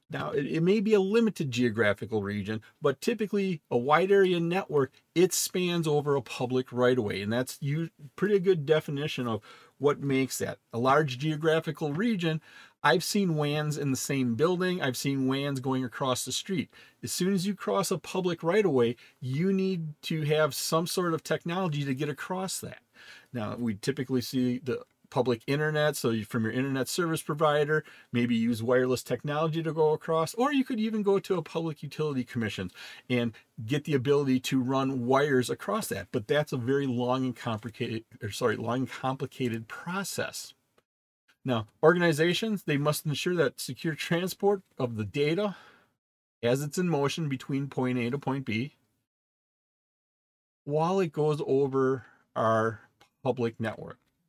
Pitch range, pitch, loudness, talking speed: 125-165 Hz, 140 Hz, -29 LUFS, 165 wpm